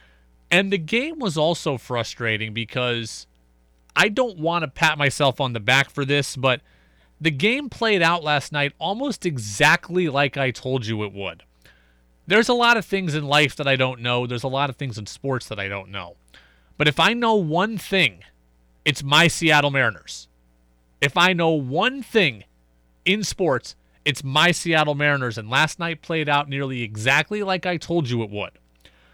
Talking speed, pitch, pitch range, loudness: 185 wpm, 140 Hz, 105-170 Hz, -21 LUFS